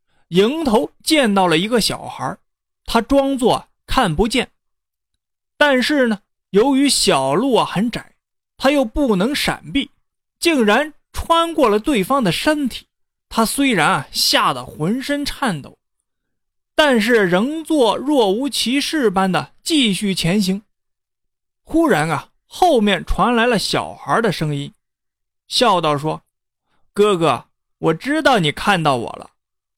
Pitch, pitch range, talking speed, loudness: 230 Hz, 190-280 Hz, 185 characters per minute, -17 LUFS